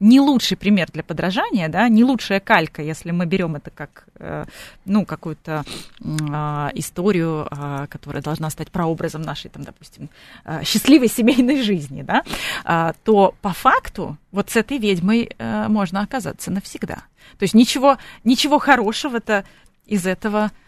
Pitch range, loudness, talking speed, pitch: 160-225 Hz, -19 LUFS, 135 wpm, 195 Hz